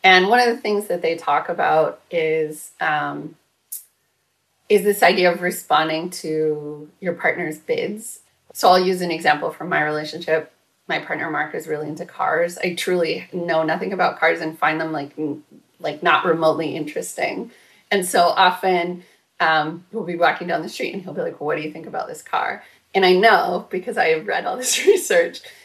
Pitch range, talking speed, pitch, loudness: 160-215 Hz, 190 wpm, 180 Hz, -20 LUFS